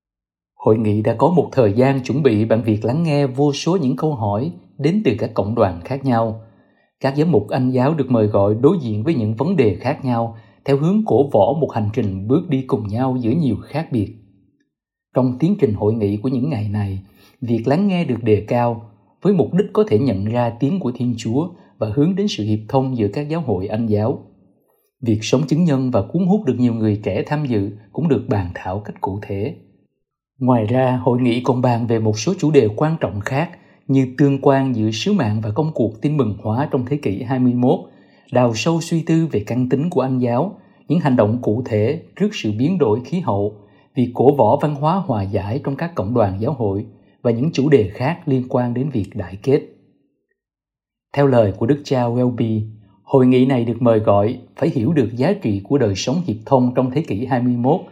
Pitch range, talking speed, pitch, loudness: 110-140 Hz, 225 wpm, 125 Hz, -18 LUFS